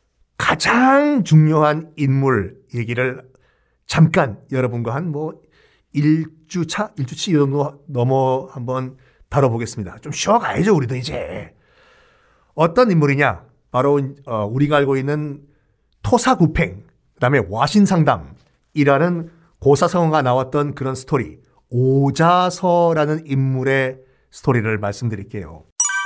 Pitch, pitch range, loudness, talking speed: 145 Hz, 130-165 Hz, -18 LUFS, 255 characters per minute